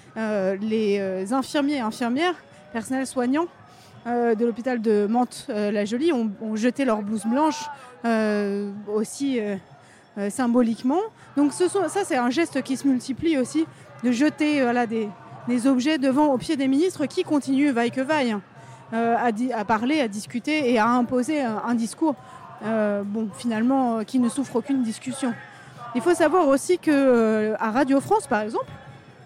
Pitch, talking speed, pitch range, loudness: 245 Hz, 175 wpm, 220-280 Hz, -23 LUFS